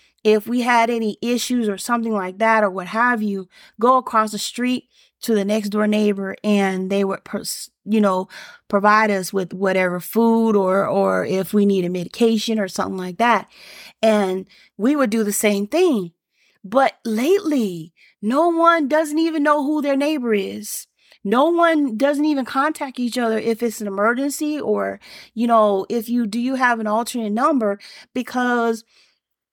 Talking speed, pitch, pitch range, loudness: 175 wpm, 220 Hz, 200-250 Hz, -19 LUFS